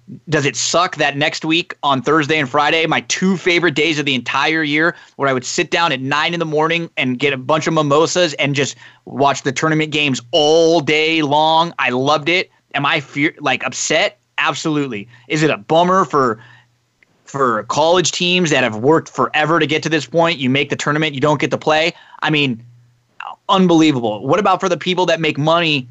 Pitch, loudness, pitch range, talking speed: 155 Hz, -15 LUFS, 140-165 Hz, 205 wpm